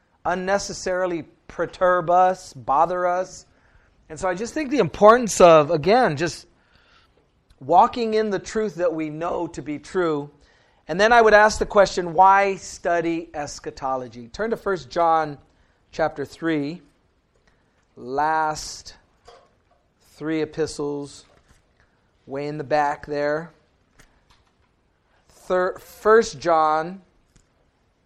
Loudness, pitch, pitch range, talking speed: -21 LUFS, 165 Hz, 145-185 Hz, 110 wpm